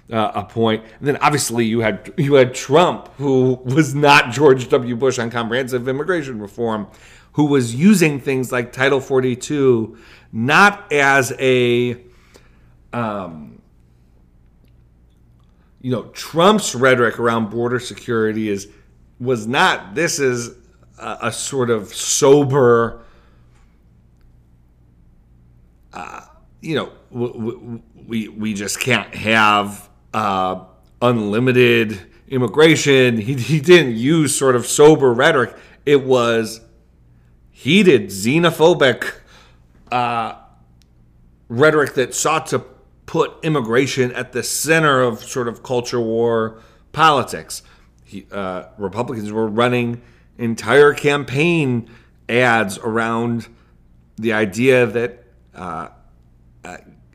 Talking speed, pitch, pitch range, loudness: 110 wpm, 115 Hz, 90-130 Hz, -17 LUFS